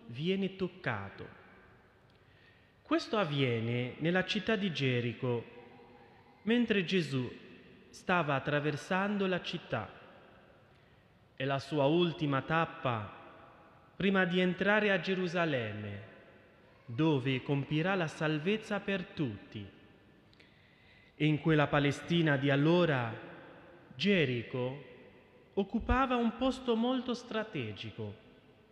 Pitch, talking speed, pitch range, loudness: 160 Hz, 90 wpm, 130-190 Hz, -32 LUFS